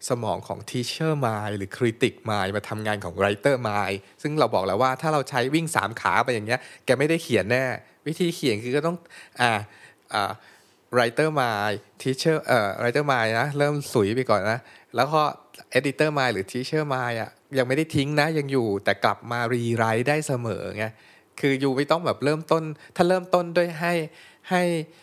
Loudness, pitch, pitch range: -24 LUFS, 130 Hz, 110-155 Hz